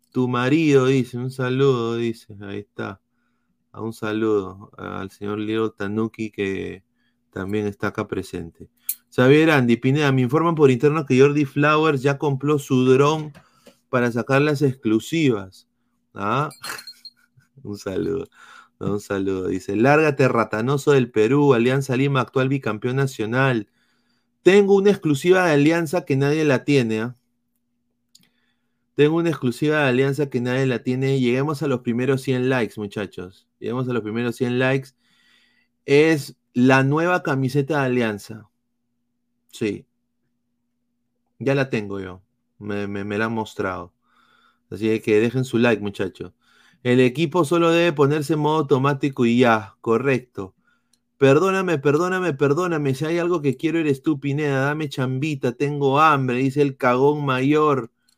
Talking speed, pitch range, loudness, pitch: 140 wpm, 115-145 Hz, -20 LUFS, 130 Hz